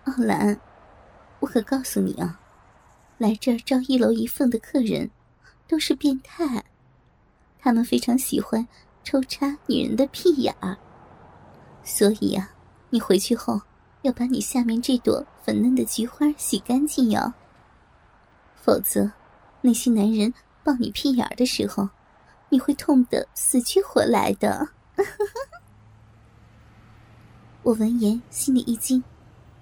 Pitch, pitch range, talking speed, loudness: 240 Hz, 205-270 Hz, 180 characters per minute, -23 LUFS